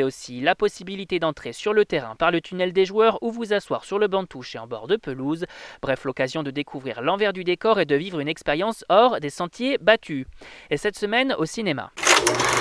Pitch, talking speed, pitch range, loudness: 180 Hz, 220 wpm, 145-210 Hz, -23 LUFS